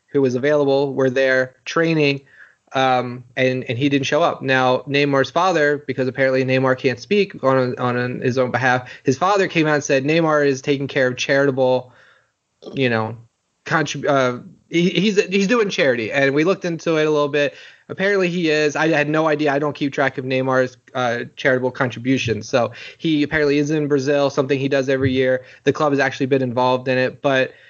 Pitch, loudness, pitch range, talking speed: 135 Hz, -19 LUFS, 130-150 Hz, 200 wpm